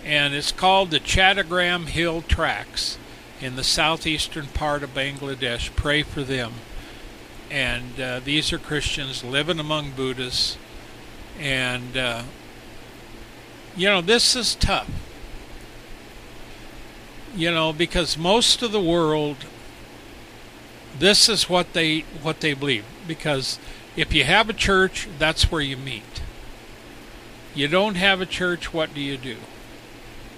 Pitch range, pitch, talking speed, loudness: 130-175 Hz, 150 Hz, 125 wpm, -21 LUFS